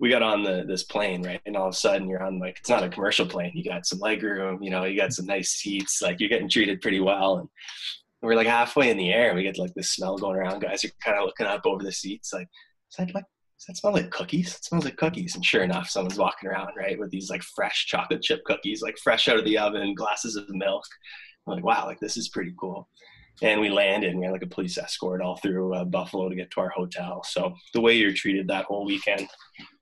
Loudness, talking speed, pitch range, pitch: -26 LUFS, 270 wpm, 95-115 Hz, 100 Hz